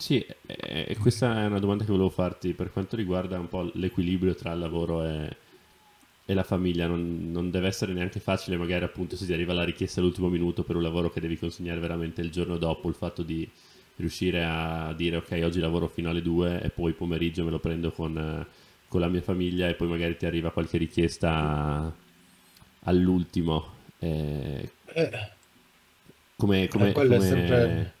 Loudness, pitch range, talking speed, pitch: -28 LUFS, 85-95 Hz, 175 wpm, 85 Hz